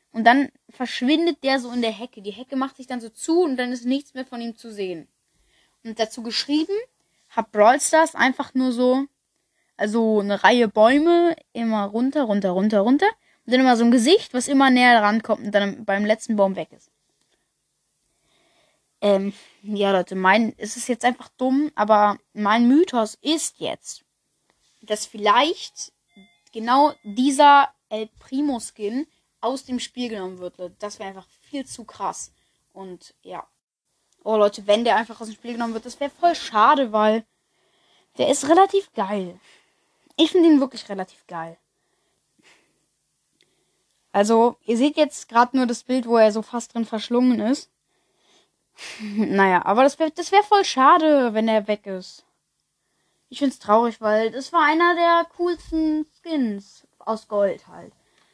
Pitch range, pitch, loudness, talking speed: 210-275 Hz, 235 Hz, -20 LUFS, 165 wpm